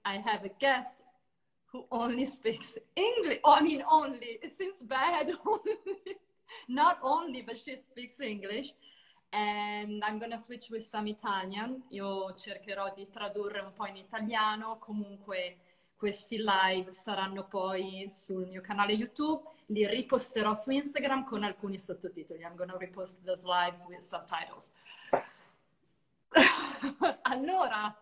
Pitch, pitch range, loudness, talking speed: 215 Hz, 195-265 Hz, -32 LUFS, 135 wpm